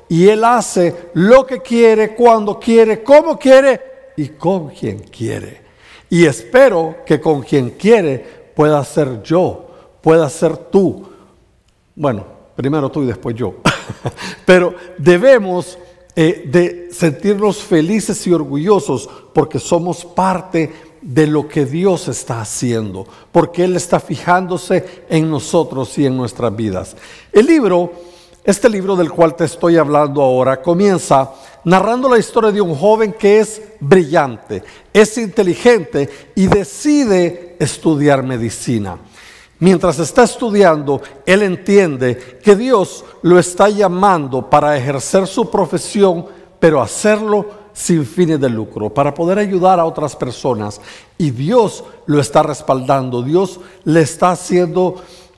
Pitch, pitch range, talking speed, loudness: 175 Hz, 145-200 Hz, 130 wpm, -14 LUFS